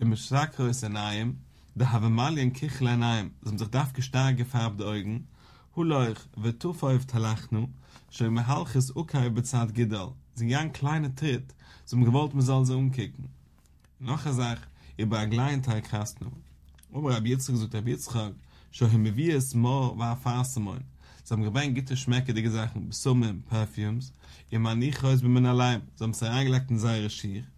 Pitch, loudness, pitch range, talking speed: 120 Hz, -28 LUFS, 110-130 Hz, 170 wpm